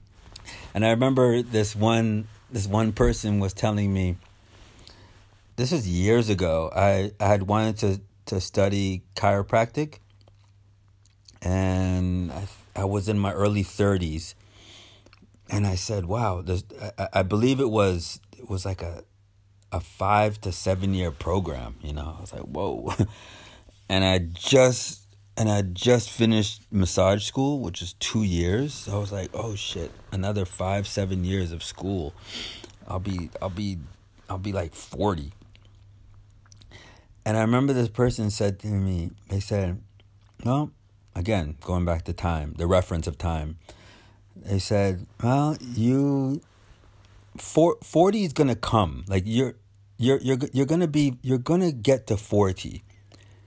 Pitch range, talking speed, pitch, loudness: 95-110 Hz, 150 wpm, 100 Hz, -25 LUFS